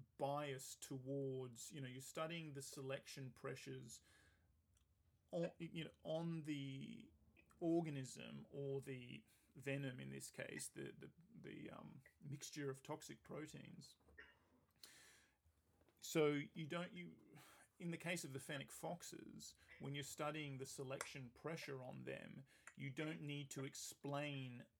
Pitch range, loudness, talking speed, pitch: 125-150 Hz, -50 LUFS, 130 wpm, 140 Hz